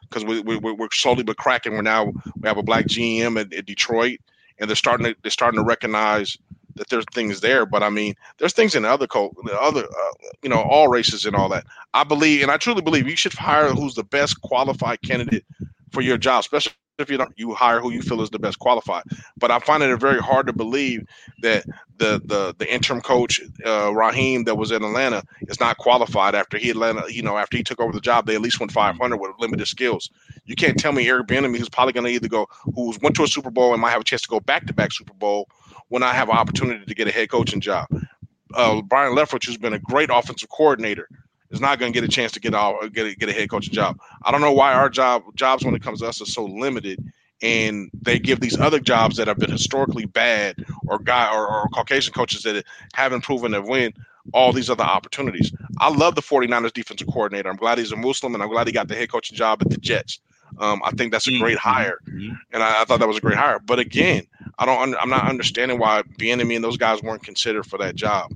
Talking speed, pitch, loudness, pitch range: 250 wpm, 120 Hz, -20 LUFS, 110-135 Hz